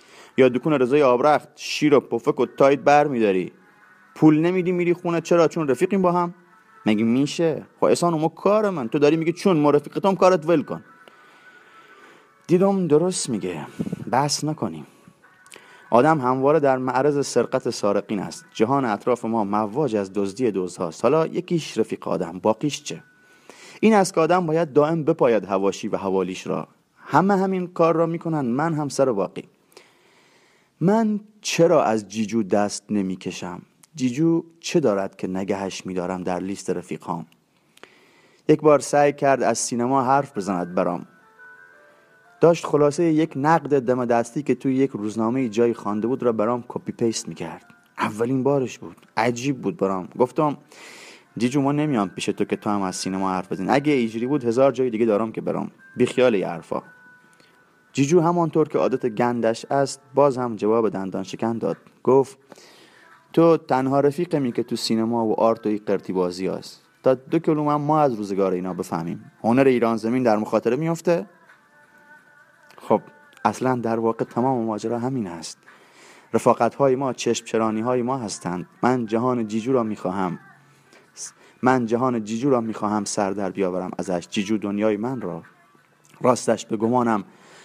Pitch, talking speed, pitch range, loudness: 125 Hz, 160 wpm, 105-155 Hz, -22 LUFS